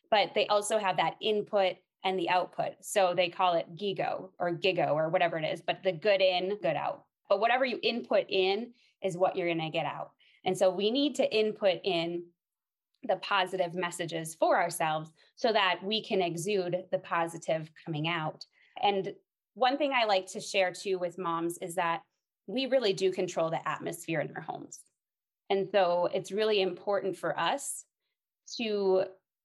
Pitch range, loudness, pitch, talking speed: 175-210 Hz, -30 LUFS, 190 Hz, 180 wpm